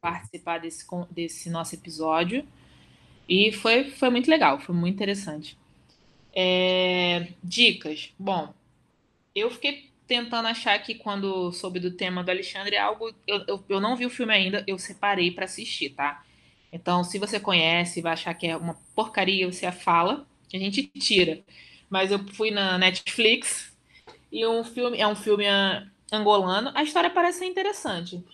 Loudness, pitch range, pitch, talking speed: -25 LUFS, 175-225 Hz, 195 Hz, 155 wpm